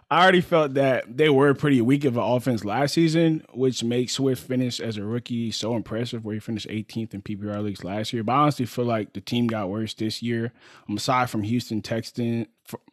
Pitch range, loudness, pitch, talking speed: 110-130 Hz, -24 LUFS, 120 Hz, 225 wpm